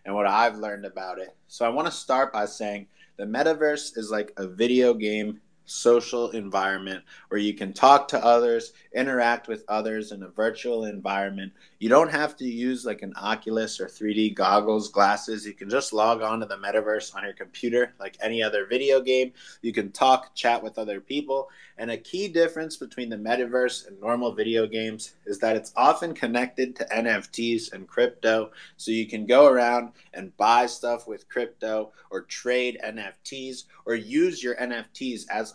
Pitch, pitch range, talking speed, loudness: 115 Hz, 105-125 Hz, 180 wpm, -25 LUFS